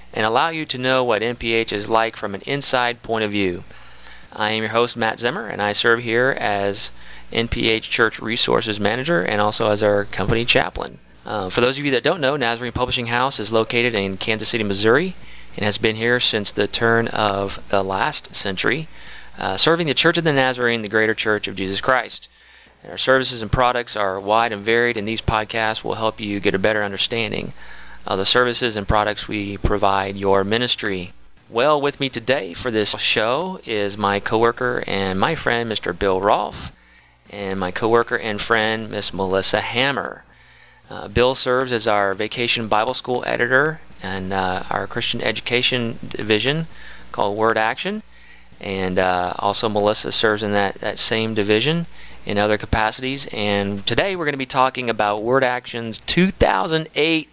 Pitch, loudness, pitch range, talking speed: 110 Hz, -19 LUFS, 100-120 Hz, 180 wpm